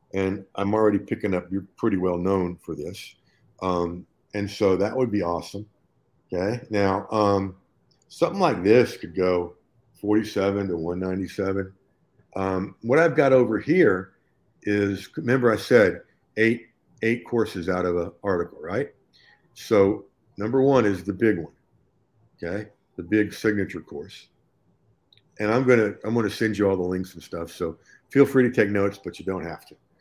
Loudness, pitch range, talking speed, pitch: -24 LUFS, 95-110 Hz, 165 wpm, 100 Hz